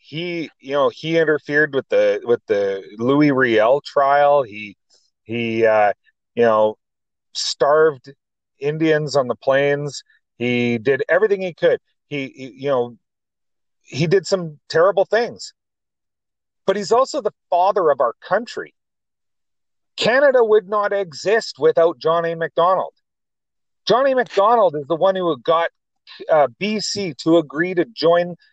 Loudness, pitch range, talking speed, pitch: -18 LUFS, 140-195 Hz, 135 wpm, 160 Hz